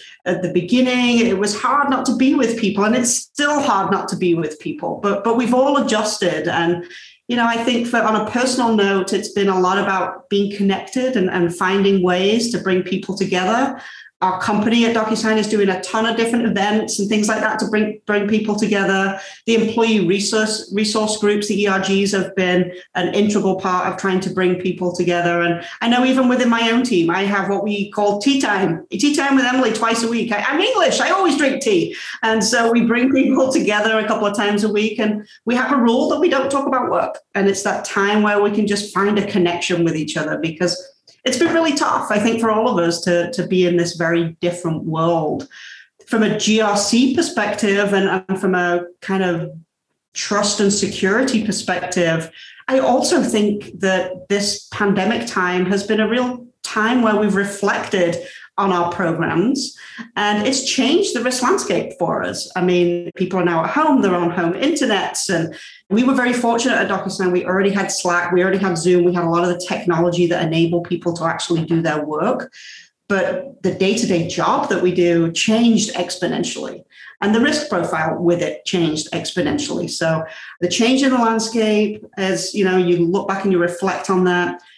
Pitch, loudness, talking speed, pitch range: 200 Hz, -18 LUFS, 205 wpm, 180-230 Hz